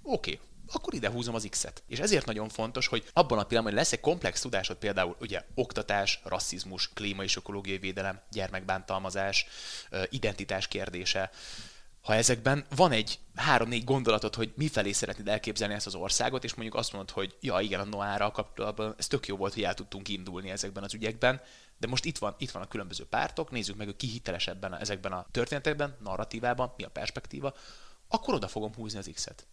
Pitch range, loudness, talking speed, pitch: 95-115 Hz, -32 LUFS, 185 wpm, 105 Hz